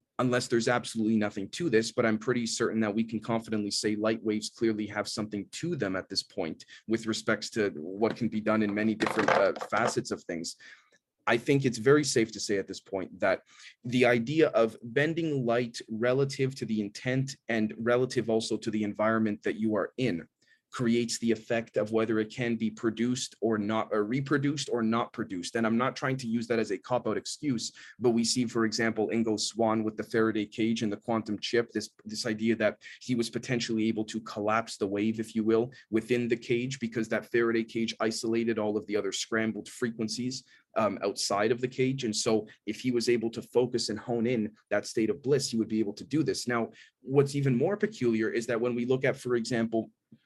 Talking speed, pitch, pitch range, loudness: 215 wpm, 115 Hz, 110-120 Hz, -30 LUFS